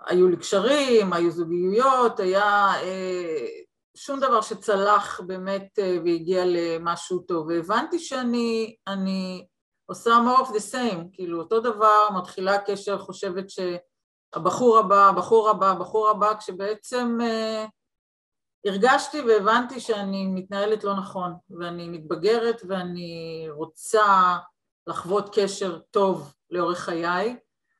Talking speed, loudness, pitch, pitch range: 110 wpm, -23 LUFS, 200 Hz, 180-225 Hz